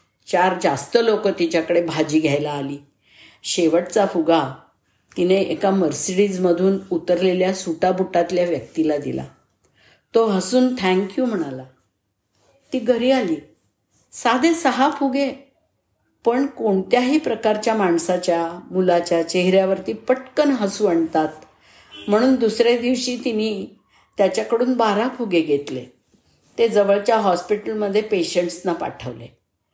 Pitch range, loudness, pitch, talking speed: 165-230 Hz, -19 LUFS, 185 Hz, 100 wpm